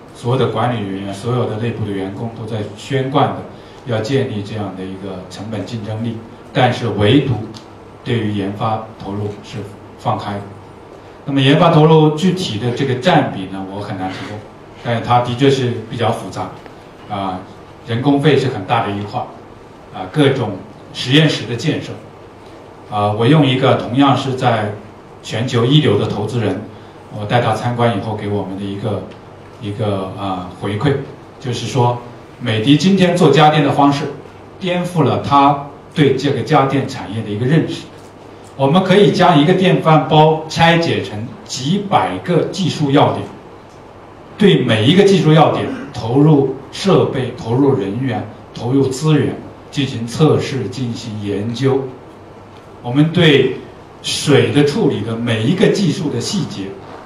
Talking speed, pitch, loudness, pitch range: 240 characters per minute, 120 Hz, -15 LUFS, 105-140 Hz